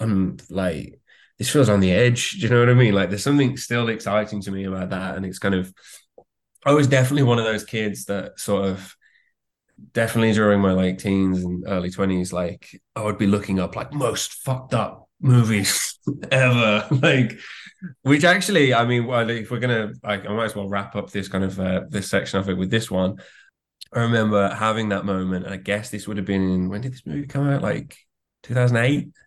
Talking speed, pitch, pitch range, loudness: 215 wpm, 105 Hz, 95-120 Hz, -21 LUFS